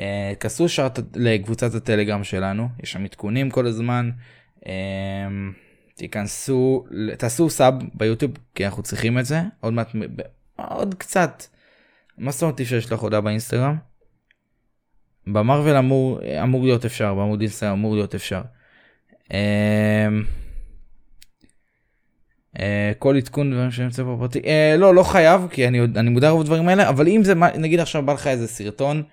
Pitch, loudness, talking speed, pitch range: 120 Hz, -20 LUFS, 140 wpm, 105-135 Hz